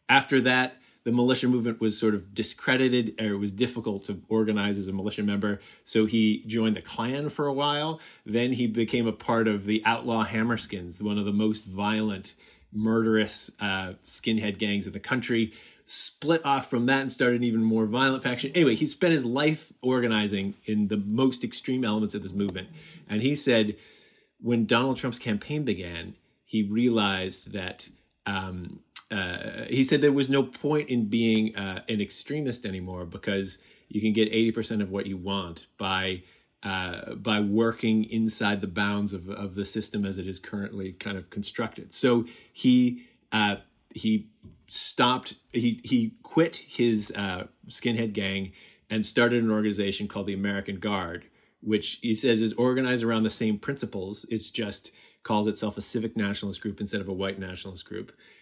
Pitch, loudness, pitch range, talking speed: 110 Hz, -27 LUFS, 100-120 Hz, 175 wpm